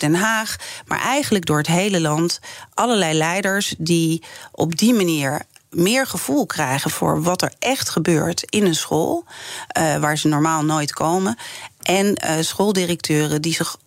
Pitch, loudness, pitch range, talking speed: 170 Hz, -19 LUFS, 160-200 Hz, 155 wpm